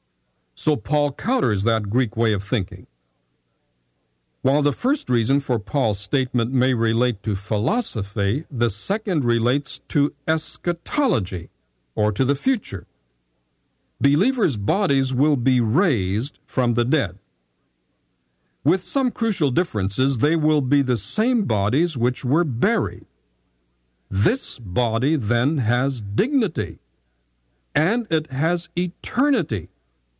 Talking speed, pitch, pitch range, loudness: 115 wpm, 120 Hz, 90-145 Hz, -22 LUFS